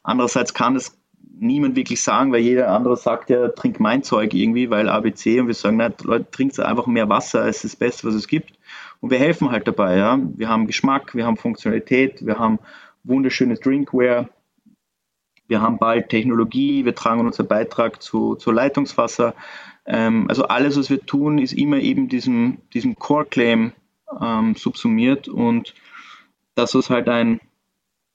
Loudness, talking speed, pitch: -19 LUFS, 170 wpm, 130 Hz